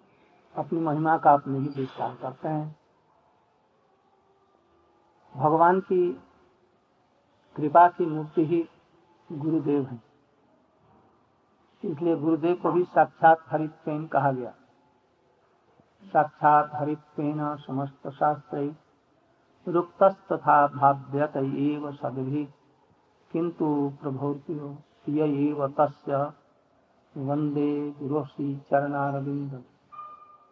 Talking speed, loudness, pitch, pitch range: 75 wpm, -26 LUFS, 150 Hz, 140-165 Hz